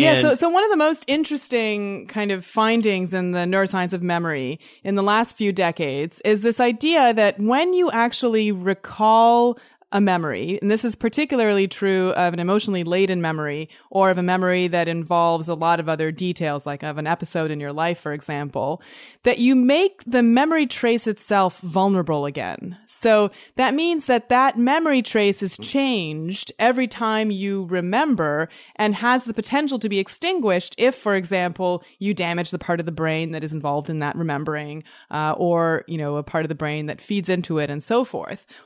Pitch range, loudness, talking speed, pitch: 170-235 Hz, -21 LUFS, 190 wpm, 195 Hz